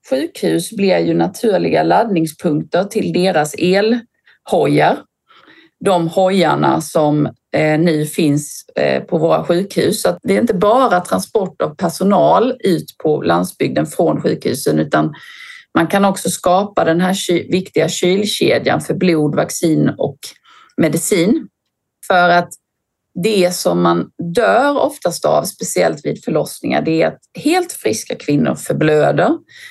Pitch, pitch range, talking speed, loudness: 175 Hz, 150-200 Hz, 125 wpm, -15 LUFS